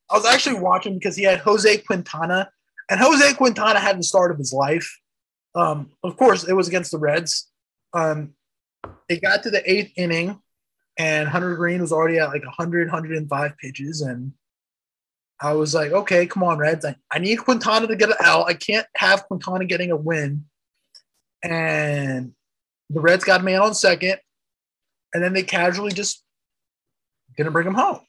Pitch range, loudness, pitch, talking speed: 150-200 Hz, -20 LUFS, 175 Hz, 175 wpm